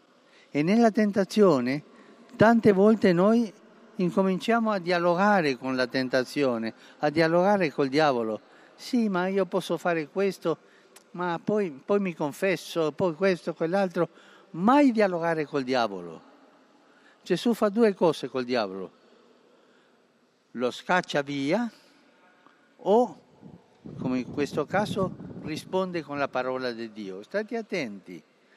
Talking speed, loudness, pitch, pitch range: 120 wpm, -26 LUFS, 180 Hz, 140-210 Hz